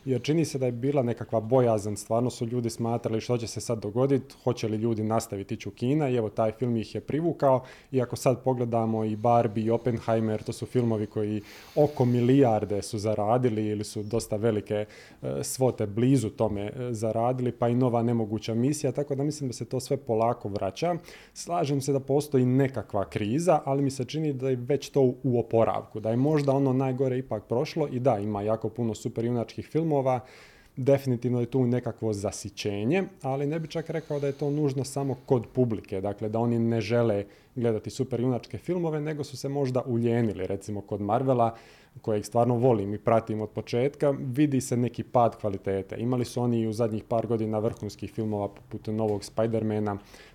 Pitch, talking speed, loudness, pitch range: 120 Hz, 190 wpm, -28 LUFS, 110-130 Hz